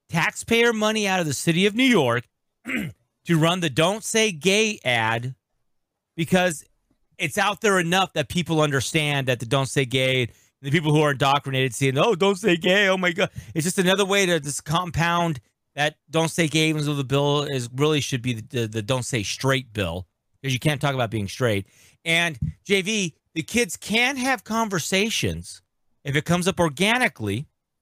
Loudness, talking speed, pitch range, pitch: -22 LUFS, 185 wpm, 130-185 Hz, 155 Hz